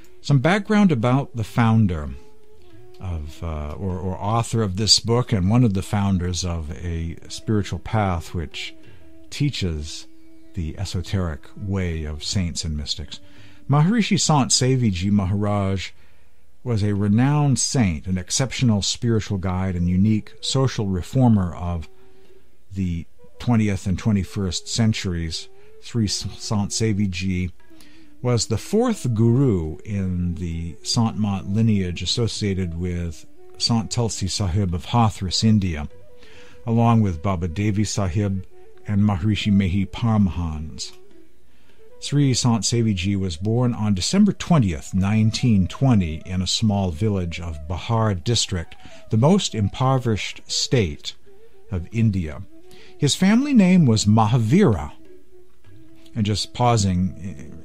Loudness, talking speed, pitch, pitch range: -21 LUFS, 115 wpm, 105 Hz, 90-120 Hz